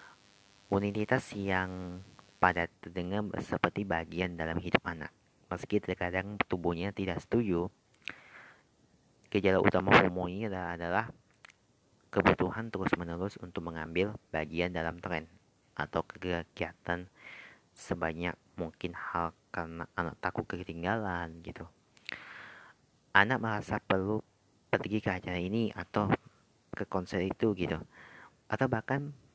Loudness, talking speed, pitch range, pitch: -33 LUFS, 100 wpm, 90-105 Hz, 95 Hz